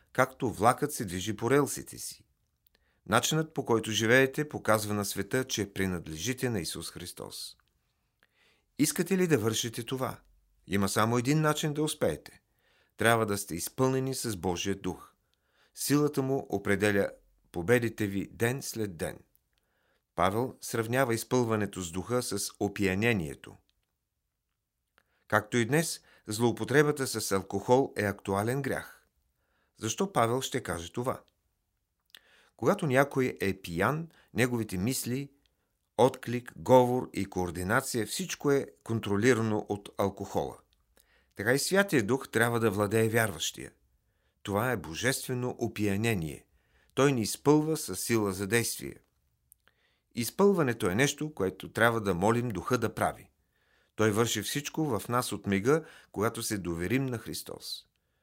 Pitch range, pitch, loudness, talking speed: 100-130 Hz, 115 Hz, -30 LUFS, 125 wpm